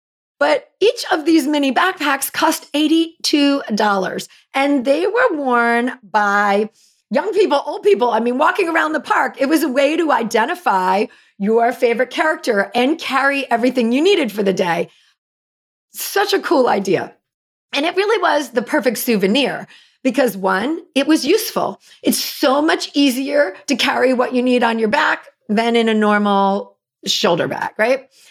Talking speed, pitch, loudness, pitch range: 160 wpm, 270 Hz, -17 LUFS, 230-315 Hz